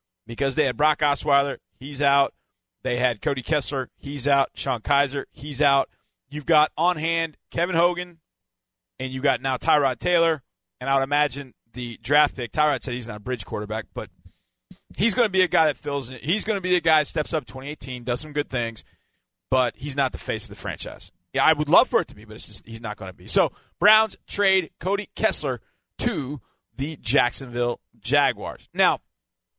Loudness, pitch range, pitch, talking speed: -24 LUFS, 120-155 Hz, 140 Hz, 200 wpm